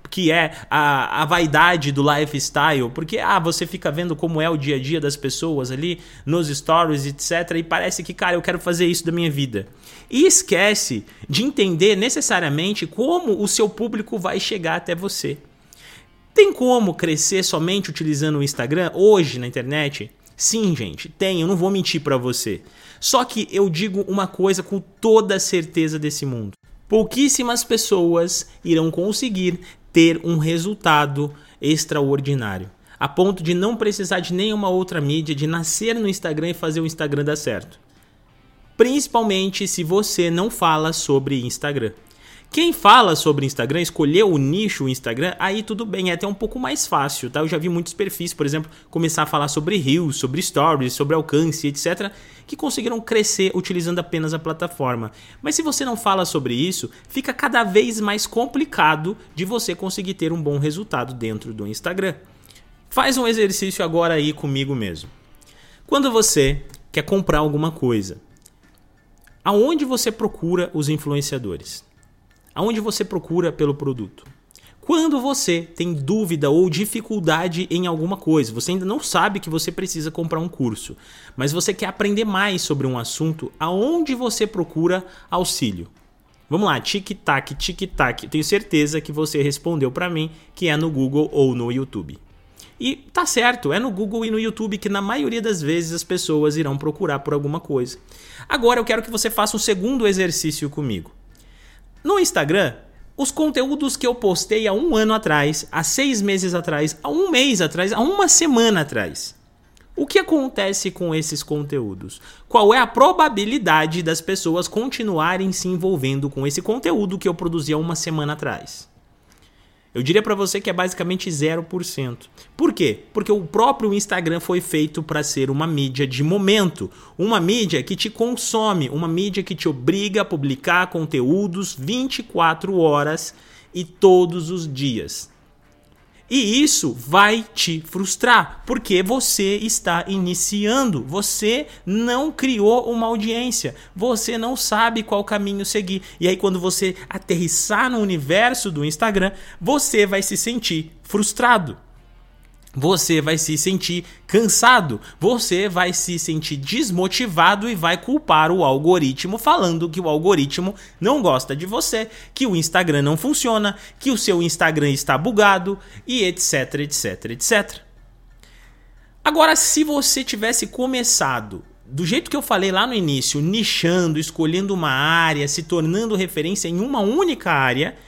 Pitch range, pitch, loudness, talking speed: 155-210 Hz, 180 Hz, -19 LUFS, 155 wpm